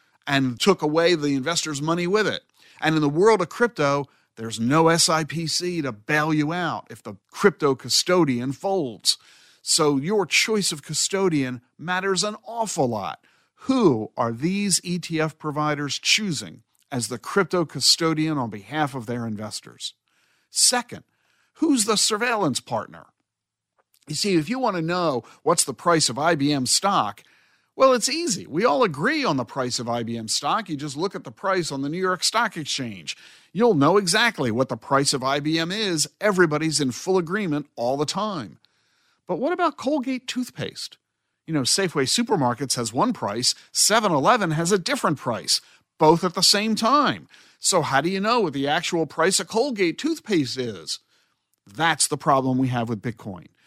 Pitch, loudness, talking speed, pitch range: 160 Hz, -22 LUFS, 170 wpm, 135-195 Hz